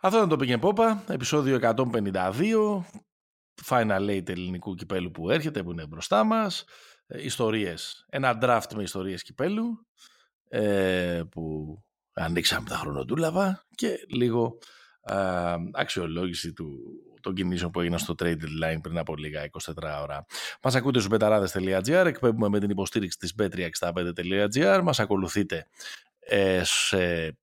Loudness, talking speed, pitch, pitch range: -27 LUFS, 135 wpm, 100 Hz, 85-130 Hz